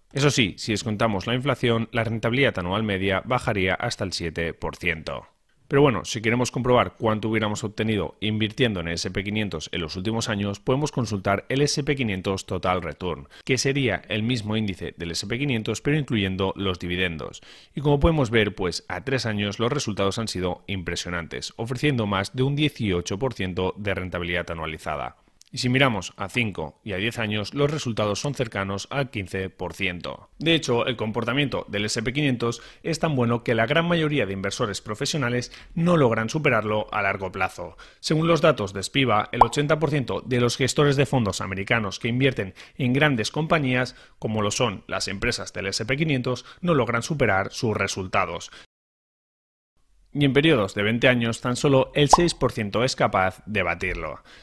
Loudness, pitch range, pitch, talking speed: -24 LUFS, 95-130 Hz, 115 Hz, 165 wpm